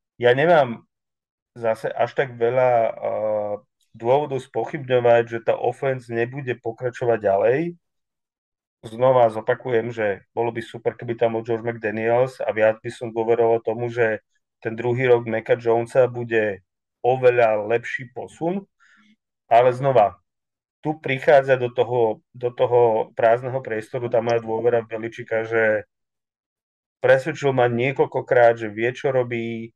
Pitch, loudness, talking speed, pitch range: 120 Hz, -21 LUFS, 130 wpm, 115-125 Hz